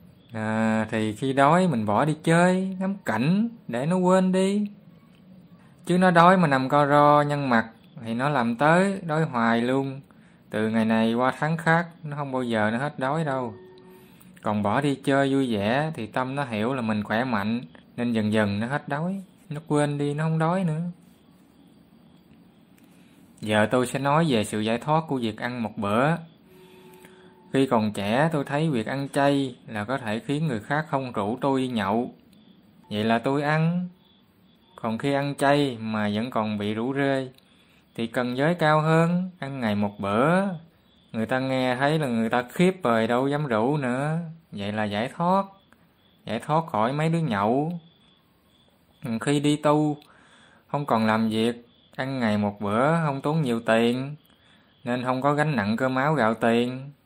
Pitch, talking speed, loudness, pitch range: 140 Hz, 180 wpm, -24 LUFS, 115-165 Hz